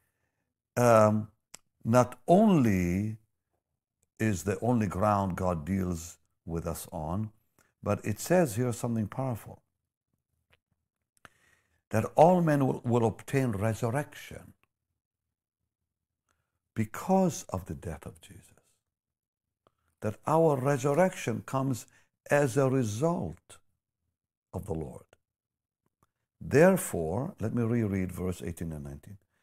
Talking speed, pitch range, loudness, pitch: 100 wpm, 90-120 Hz, -29 LUFS, 105 Hz